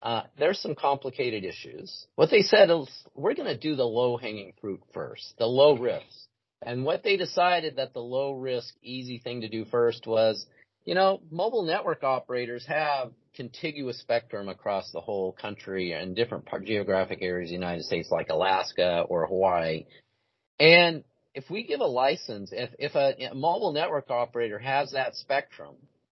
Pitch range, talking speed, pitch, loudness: 110-145 Hz, 170 wpm, 125 Hz, -27 LUFS